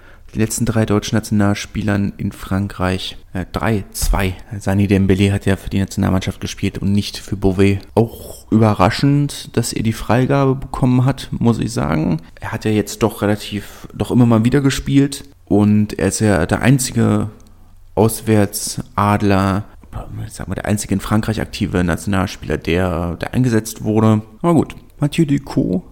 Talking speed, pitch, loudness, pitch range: 155 wpm, 105 Hz, -17 LUFS, 95-115 Hz